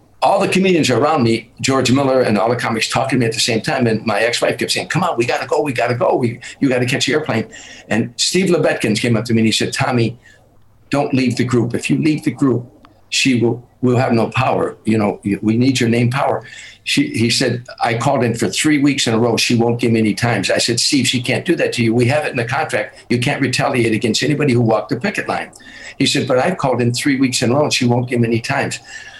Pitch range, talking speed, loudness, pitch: 115-140 Hz, 270 wpm, -16 LUFS, 125 Hz